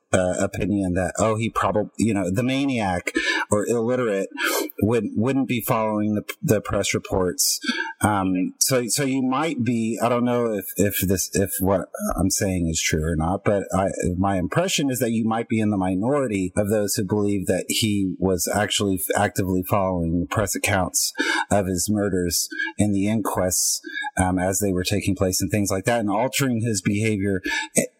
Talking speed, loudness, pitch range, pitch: 180 wpm, -22 LUFS, 95-115 Hz, 100 Hz